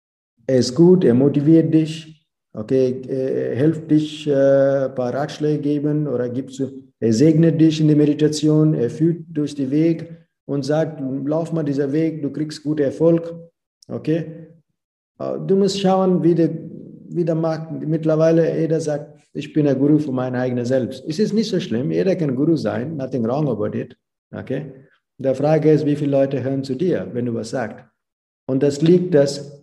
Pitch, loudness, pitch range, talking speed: 150 Hz, -19 LUFS, 135-160 Hz, 185 wpm